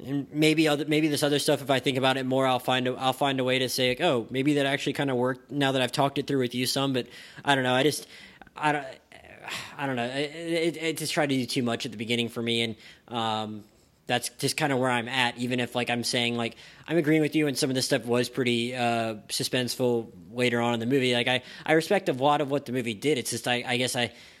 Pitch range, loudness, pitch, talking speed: 120-145 Hz, -26 LUFS, 130 Hz, 280 wpm